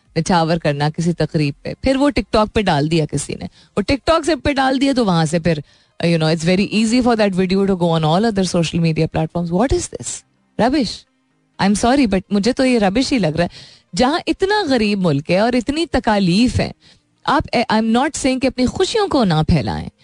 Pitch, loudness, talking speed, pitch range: 195 Hz, -17 LUFS, 220 wpm, 165-255 Hz